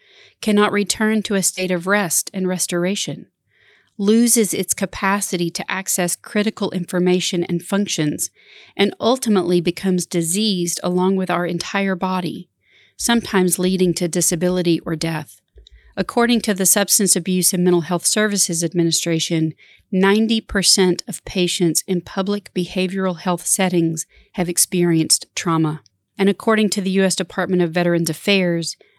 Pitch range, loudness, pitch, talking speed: 175-200 Hz, -18 LUFS, 185 Hz, 130 wpm